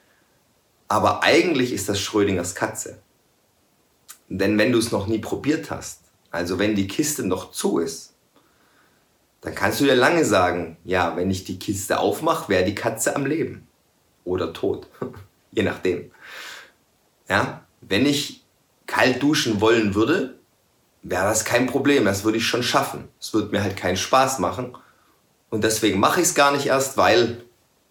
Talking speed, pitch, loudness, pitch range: 160 wpm, 110 Hz, -21 LUFS, 95-125 Hz